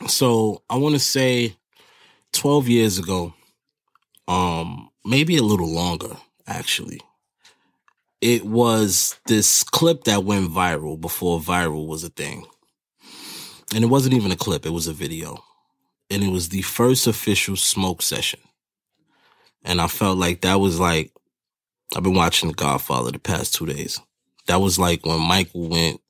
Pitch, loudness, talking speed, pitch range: 95 Hz, -20 LUFS, 150 wpm, 85-115 Hz